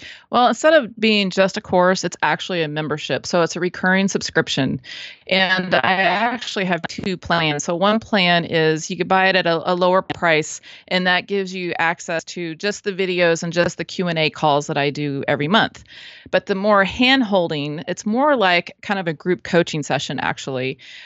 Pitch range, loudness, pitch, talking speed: 165-195 Hz, -19 LUFS, 180 Hz, 200 wpm